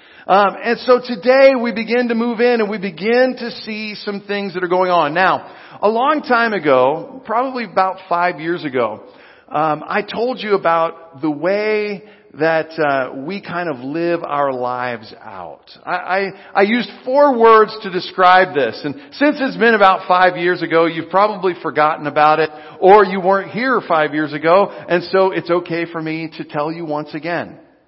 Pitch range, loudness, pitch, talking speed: 160-215 Hz, -16 LUFS, 185 Hz, 185 wpm